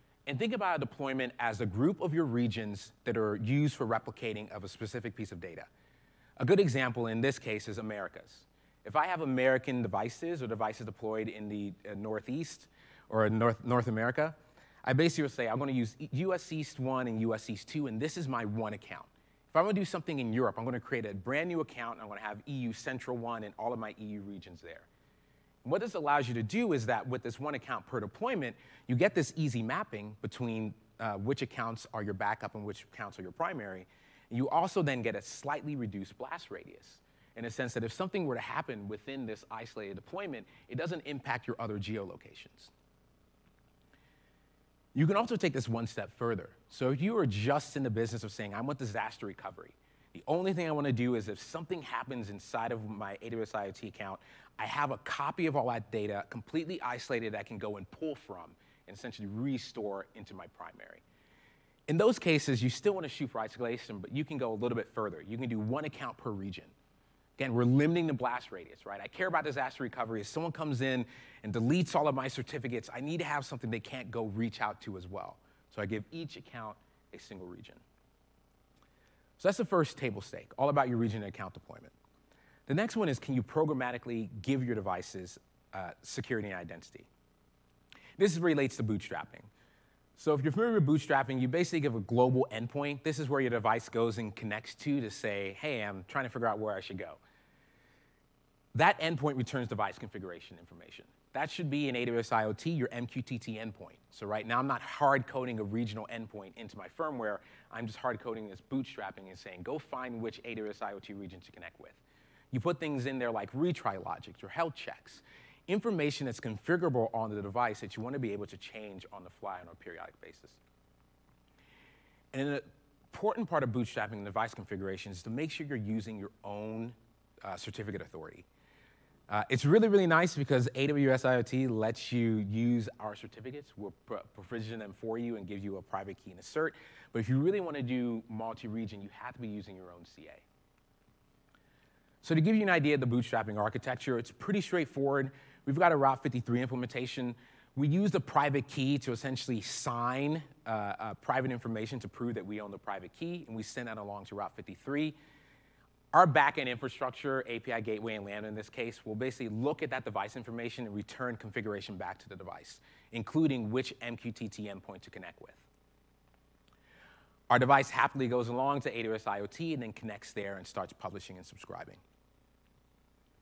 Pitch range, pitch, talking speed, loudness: 105-140 Hz, 120 Hz, 200 wpm, -34 LUFS